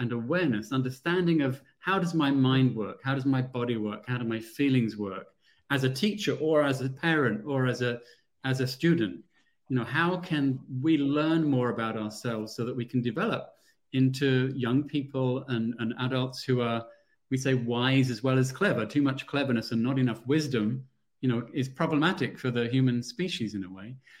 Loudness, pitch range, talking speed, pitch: -28 LUFS, 120-145 Hz, 195 wpm, 130 Hz